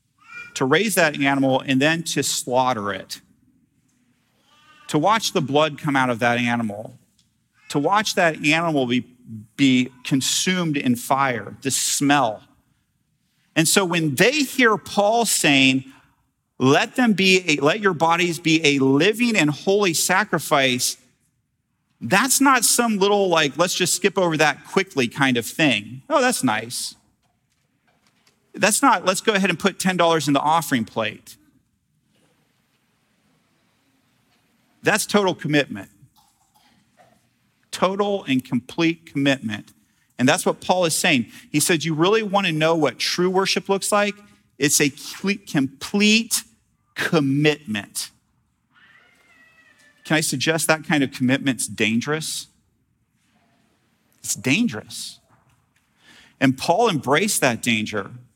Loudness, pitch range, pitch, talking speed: -20 LUFS, 135-195 Hz, 155 Hz, 125 wpm